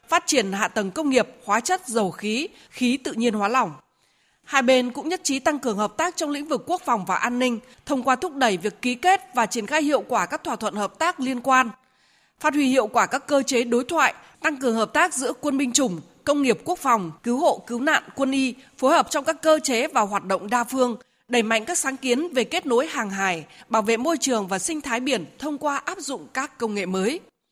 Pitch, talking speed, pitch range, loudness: 255 Hz, 250 wpm, 230-295 Hz, -23 LUFS